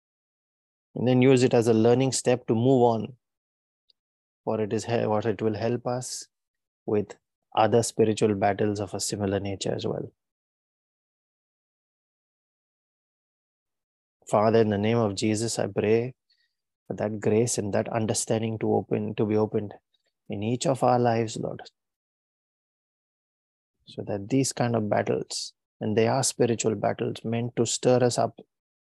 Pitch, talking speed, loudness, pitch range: 110 Hz, 145 wpm, -25 LUFS, 105-120 Hz